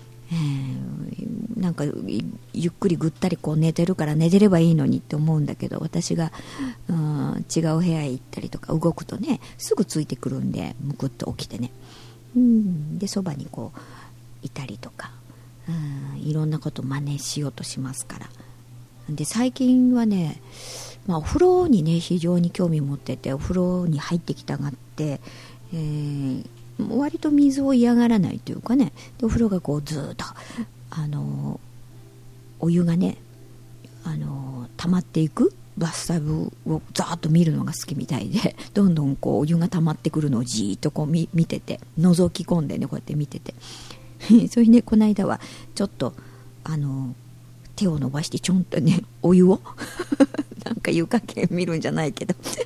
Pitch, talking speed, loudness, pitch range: 155 Hz, 320 characters per minute, -23 LUFS, 130-180 Hz